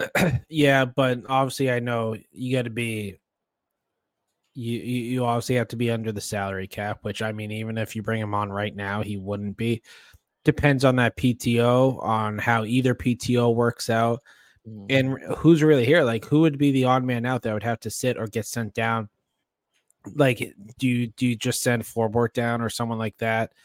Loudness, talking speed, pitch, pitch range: -24 LUFS, 195 wpm, 120 Hz, 110-125 Hz